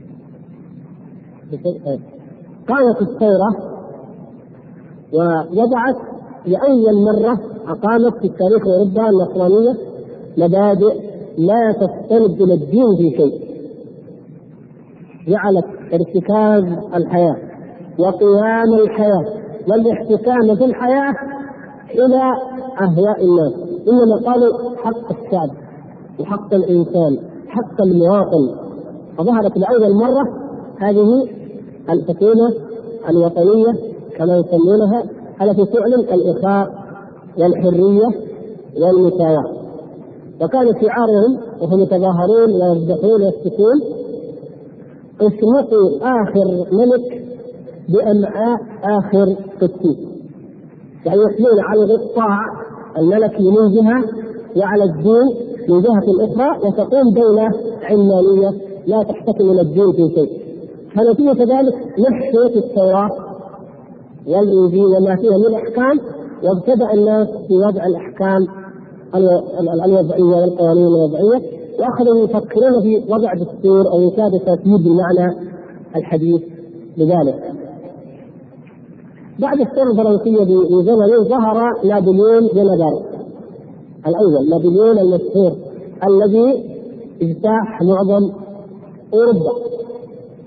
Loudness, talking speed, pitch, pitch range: -14 LUFS, 85 wpm, 205 Hz, 185-225 Hz